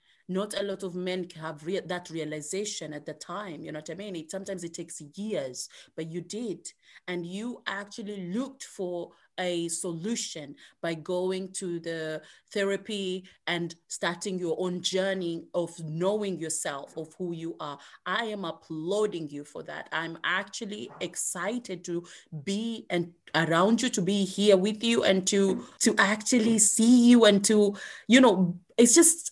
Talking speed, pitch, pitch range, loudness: 165 wpm, 185 Hz, 170-205 Hz, -27 LUFS